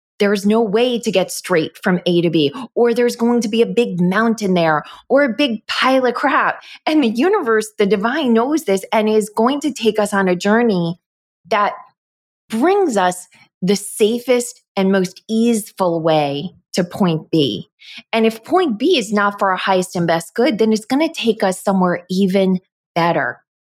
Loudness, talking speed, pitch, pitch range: -17 LUFS, 190 wpm, 215 Hz, 185-235 Hz